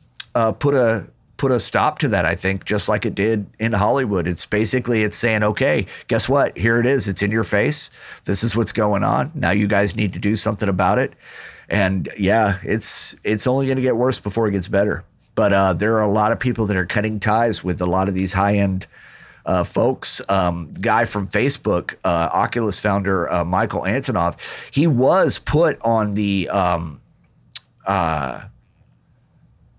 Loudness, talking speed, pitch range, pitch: -19 LUFS, 190 wpm, 95-110 Hz, 105 Hz